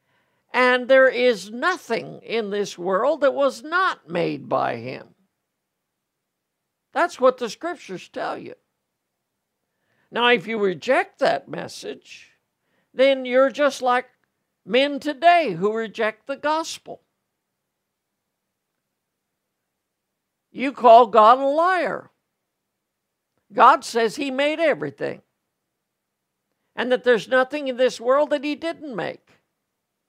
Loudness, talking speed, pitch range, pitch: -20 LUFS, 110 wpm, 230-295 Hz, 255 Hz